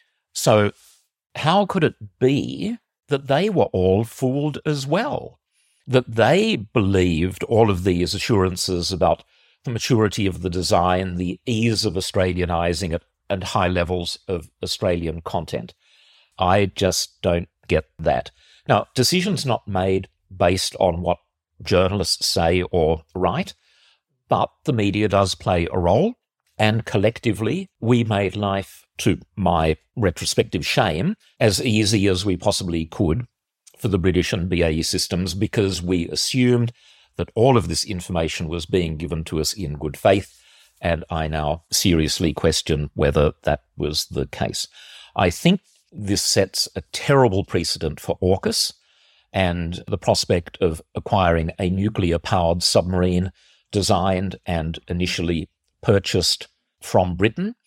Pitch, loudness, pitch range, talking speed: 95 Hz, -21 LUFS, 85-110 Hz, 135 wpm